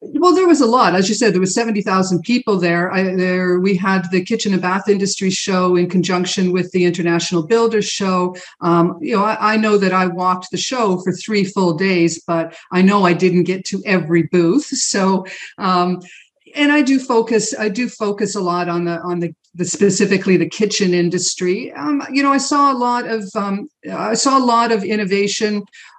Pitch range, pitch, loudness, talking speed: 180-220 Hz, 190 Hz, -16 LUFS, 210 wpm